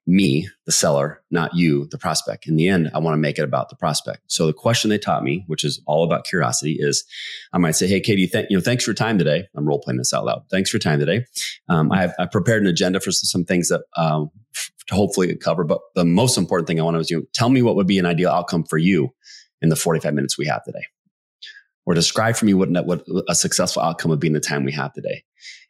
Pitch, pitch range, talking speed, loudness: 85 Hz, 75-95 Hz, 265 wpm, -20 LUFS